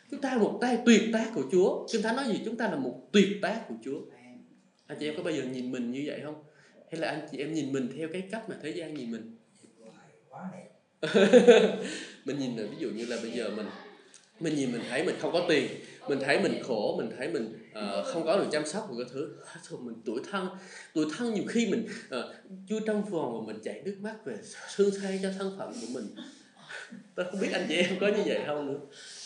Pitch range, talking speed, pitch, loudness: 155-220 Hz, 240 wpm, 200 Hz, -30 LUFS